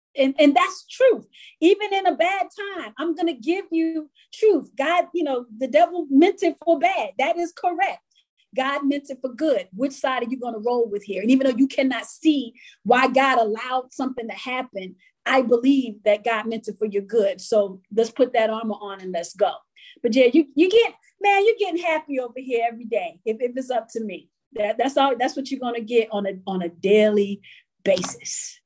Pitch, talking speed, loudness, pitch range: 265 Hz, 215 wpm, -22 LUFS, 225-335 Hz